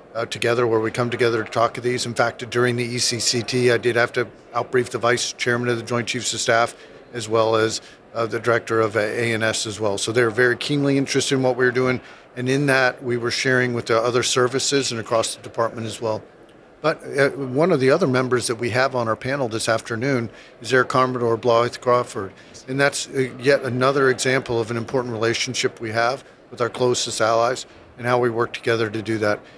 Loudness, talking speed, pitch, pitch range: -21 LUFS, 220 wpm, 120 Hz, 115-125 Hz